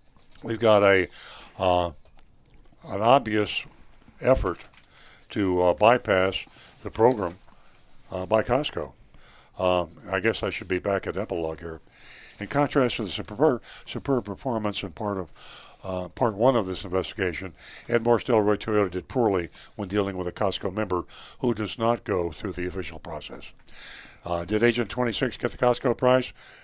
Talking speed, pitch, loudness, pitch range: 160 wpm, 100 Hz, -25 LUFS, 90-115 Hz